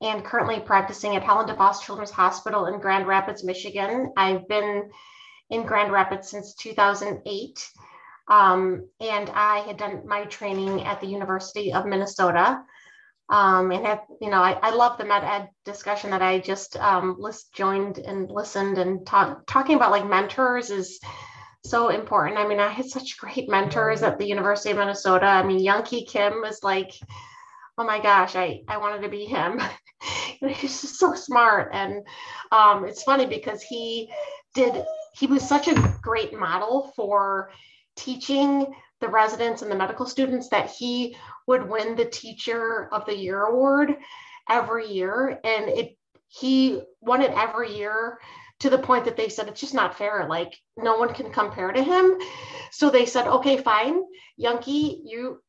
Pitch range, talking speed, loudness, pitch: 200-255 Hz, 170 wpm, -23 LUFS, 215 Hz